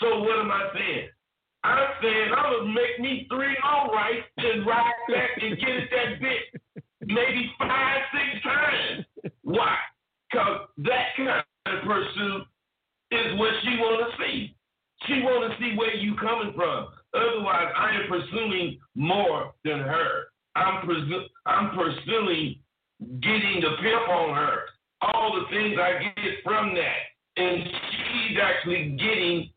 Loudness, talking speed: -25 LUFS, 150 wpm